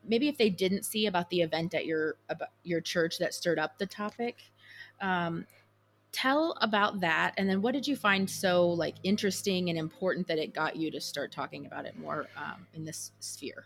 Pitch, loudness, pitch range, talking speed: 180 Hz, -31 LUFS, 160-205 Hz, 200 wpm